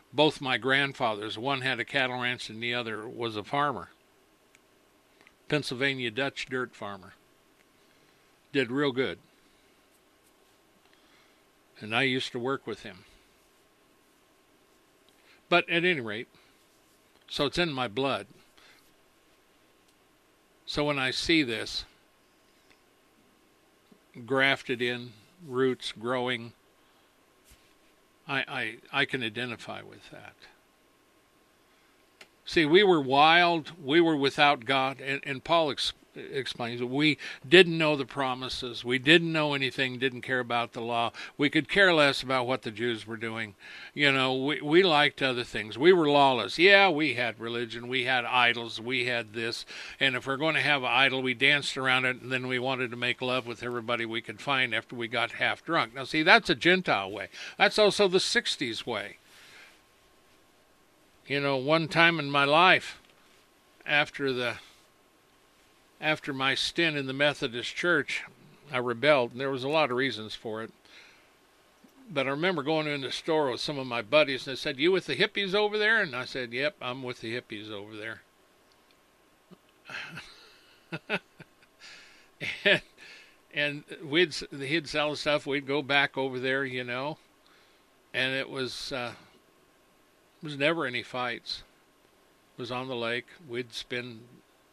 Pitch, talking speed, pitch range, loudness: 135 Hz, 150 wpm, 125-155 Hz, -27 LUFS